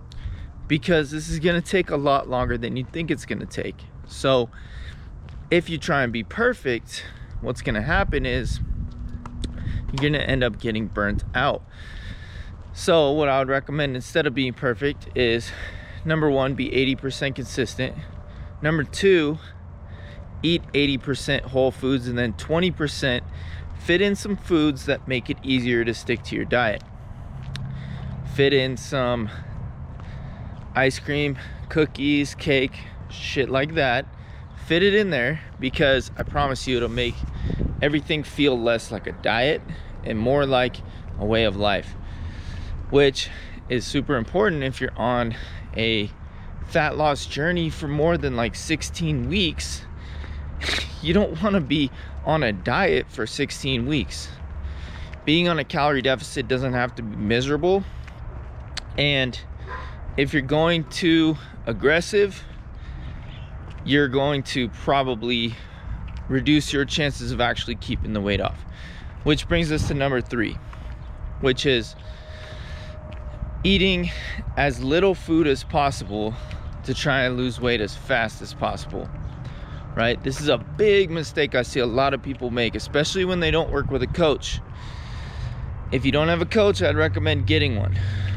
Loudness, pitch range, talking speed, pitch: -23 LUFS, 95-145 Hz, 145 wpm, 125 Hz